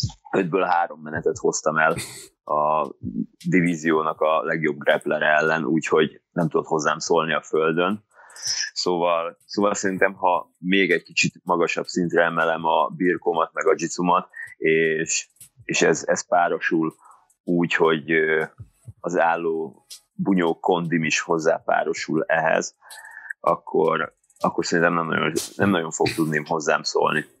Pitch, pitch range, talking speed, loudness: 85 Hz, 80-90 Hz, 125 wpm, -22 LUFS